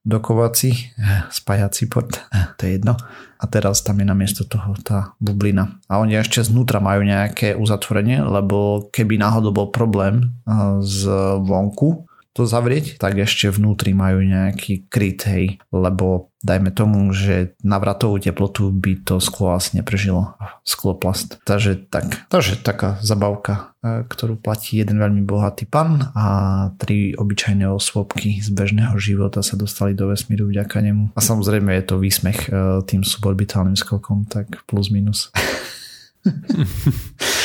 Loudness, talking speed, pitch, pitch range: -19 LUFS, 135 wpm, 100 Hz, 100-110 Hz